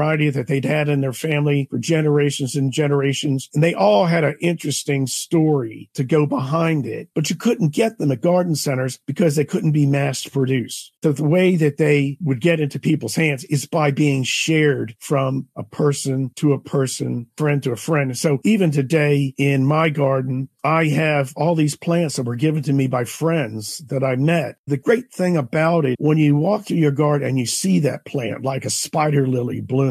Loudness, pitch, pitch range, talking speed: -19 LUFS, 145 Hz, 135-160 Hz, 205 wpm